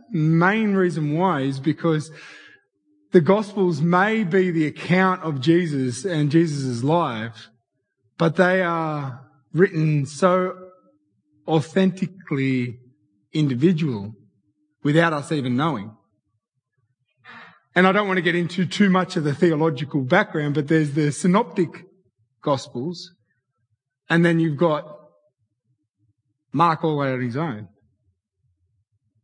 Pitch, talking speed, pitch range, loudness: 155 Hz, 115 wpm, 125-180 Hz, -21 LUFS